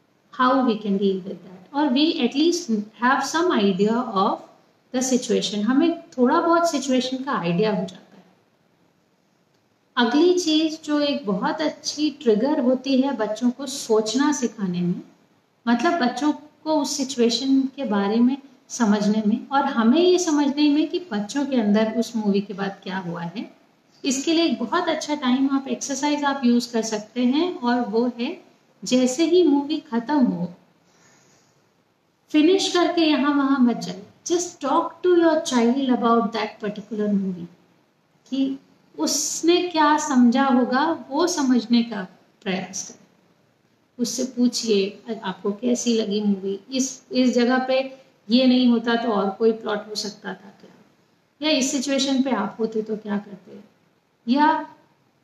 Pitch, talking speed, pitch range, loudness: 250 Hz, 150 wpm, 215-290 Hz, -22 LUFS